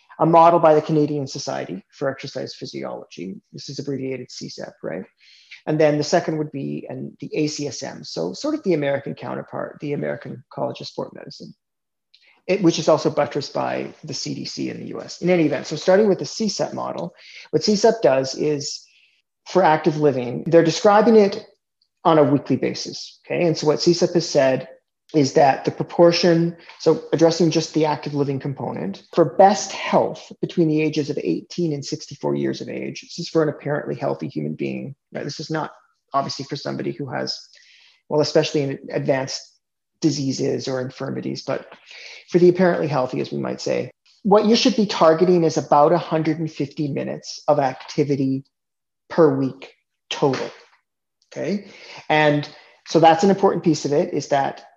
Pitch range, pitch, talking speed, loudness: 140-170 Hz, 155 Hz, 175 wpm, -20 LUFS